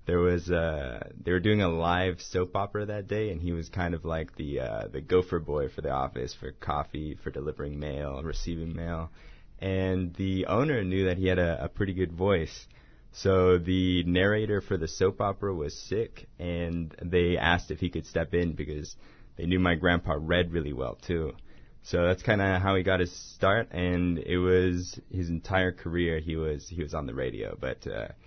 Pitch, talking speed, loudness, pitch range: 90 Hz, 205 wpm, -29 LUFS, 80-95 Hz